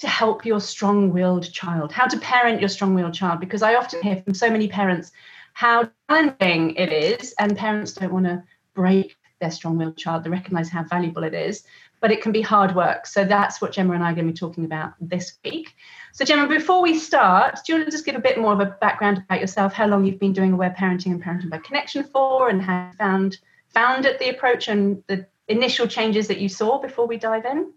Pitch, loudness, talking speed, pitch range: 200 Hz, -21 LUFS, 240 wpm, 180-240 Hz